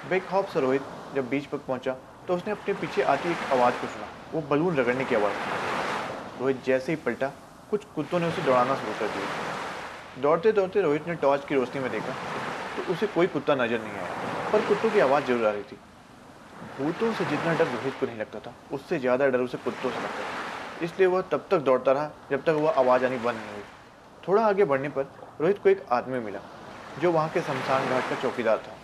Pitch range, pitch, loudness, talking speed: 125-175 Hz, 140 Hz, -27 LUFS, 225 wpm